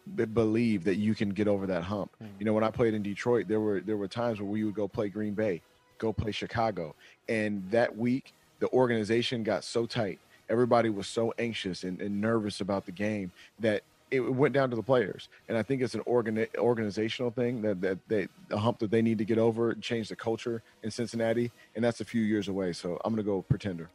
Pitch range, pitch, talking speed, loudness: 105-115 Hz, 110 Hz, 230 wpm, -30 LUFS